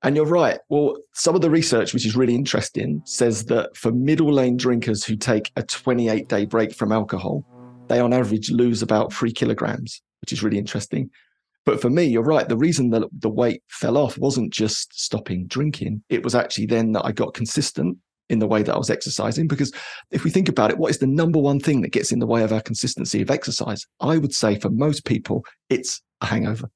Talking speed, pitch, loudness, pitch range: 220 wpm, 120 Hz, -21 LUFS, 110-140 Hz